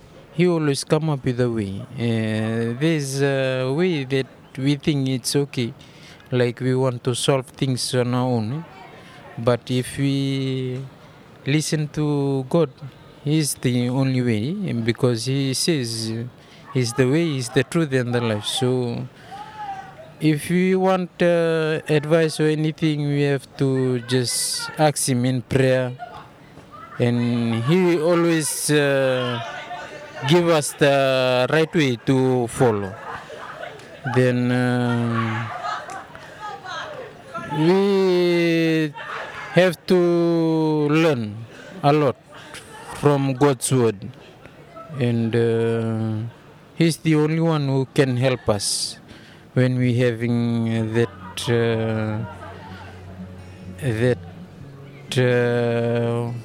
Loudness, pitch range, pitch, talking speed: -21 LUFS, 120-155 Hz, 135 Hz, 110 wpm